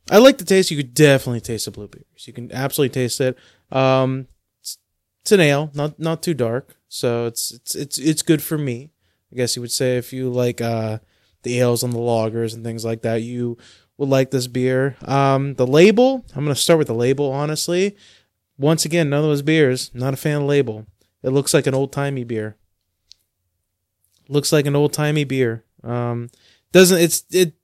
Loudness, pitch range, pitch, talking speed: -19 LUFS, 115-145 Hz, 130 Hz, 200 wpm